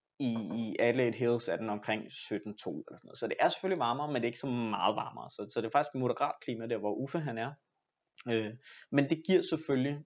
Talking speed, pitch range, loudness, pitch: 235 wpm, 115-150 Hz, -33 LUFS, 125 Hz